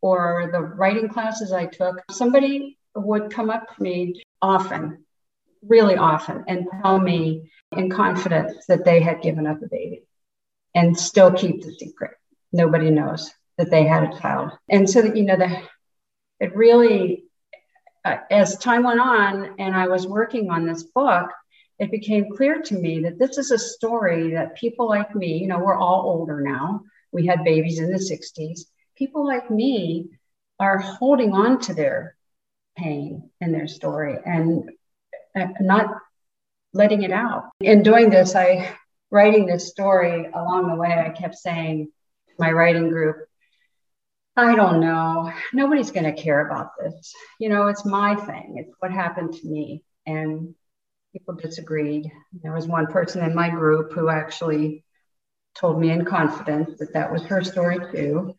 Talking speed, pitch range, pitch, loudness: 160 wpm, 165-210 Hz, 180 Hz, -20 LUFS